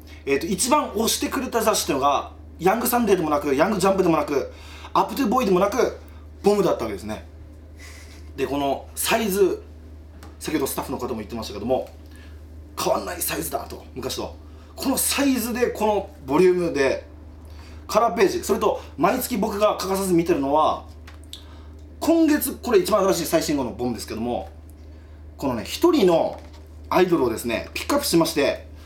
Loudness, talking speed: -22 LUFS, 375 characters per minute